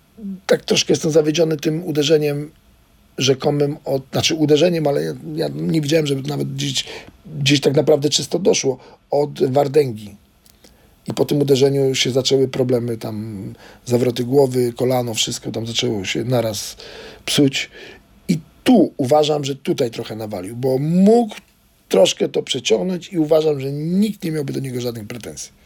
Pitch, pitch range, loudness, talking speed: 140 Hz, 125-155 Hz, -18 LUFS, 150 wpm